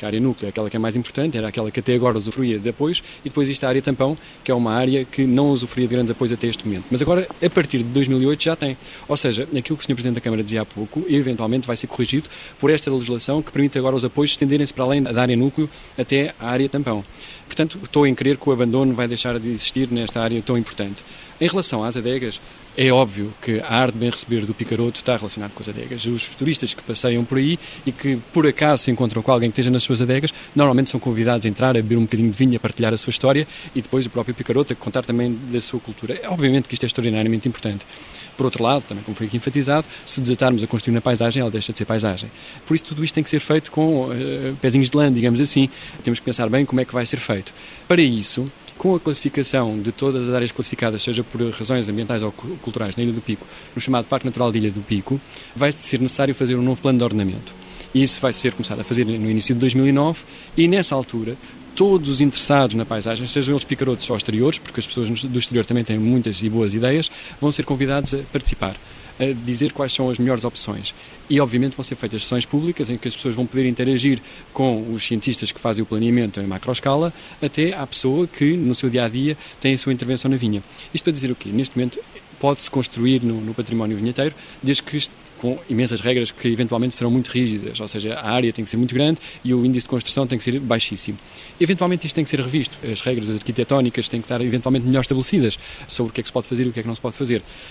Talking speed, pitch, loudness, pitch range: 245 wpm, 125 Hz, -20 LUFS, 115-140 Hz